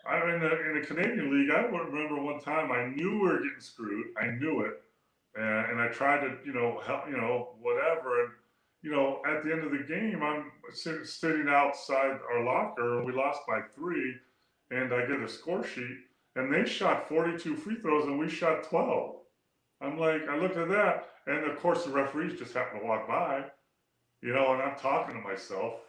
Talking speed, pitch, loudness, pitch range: 205 wpm, 145 Hz, -31 LUFS, 130-165 Hz